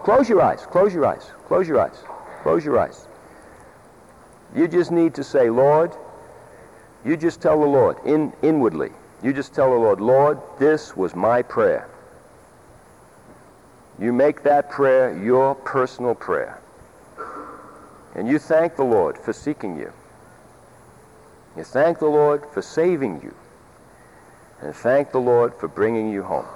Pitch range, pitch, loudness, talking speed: 130-160 Hz, 145 Hz, -20 LUFS, 145 wpm